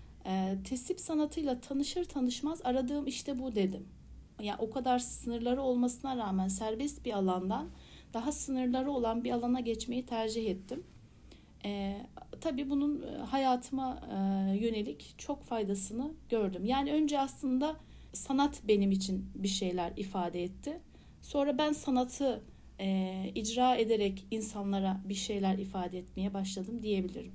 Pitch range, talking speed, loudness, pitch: 195-270 Hz, 125 wpm, -34 LUFS, 235 Hz